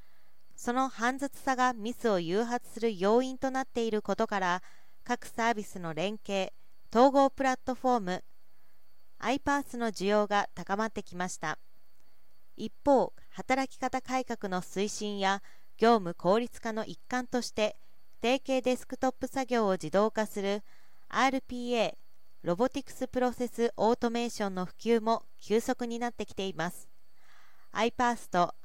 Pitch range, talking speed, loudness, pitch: 200-255 Hz, 295 characters per minute, -31 LUFS, 230 Hz